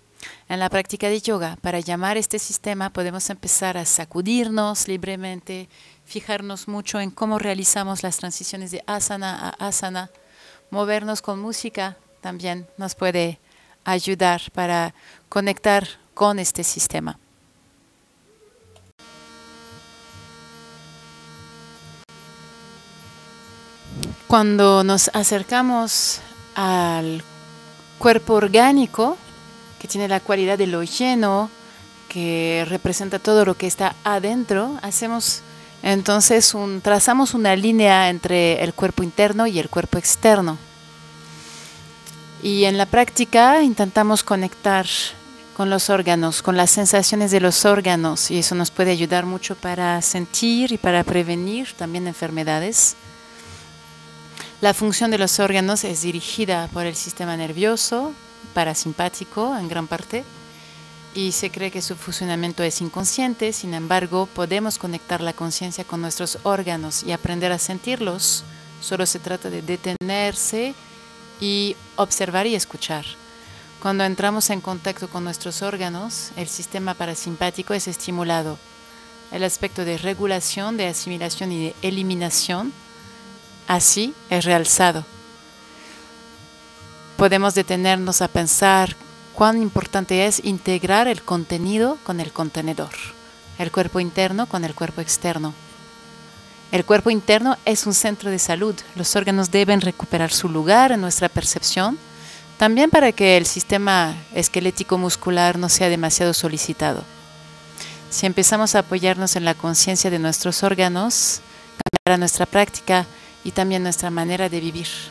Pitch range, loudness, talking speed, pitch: 170-205 Hz, -19 LUFS, 120 wpm, 185 Hz